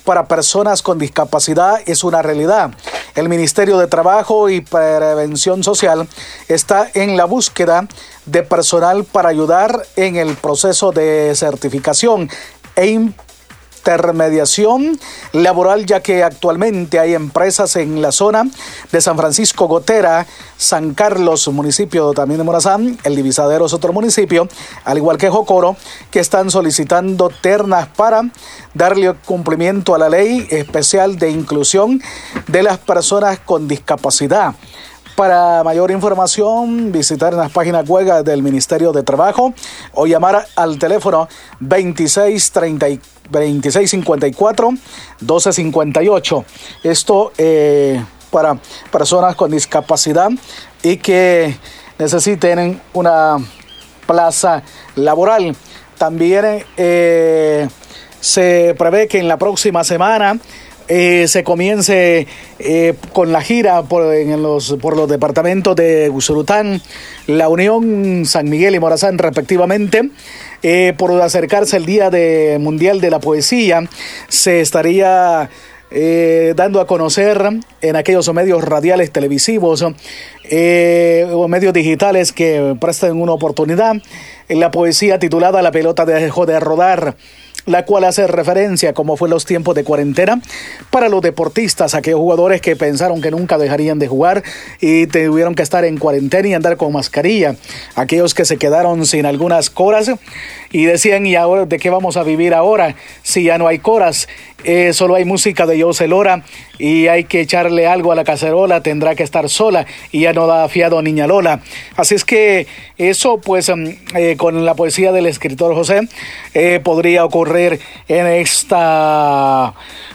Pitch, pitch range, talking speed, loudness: 170 Hz, 160-190 Hz, 135 wpm, -12 LUFS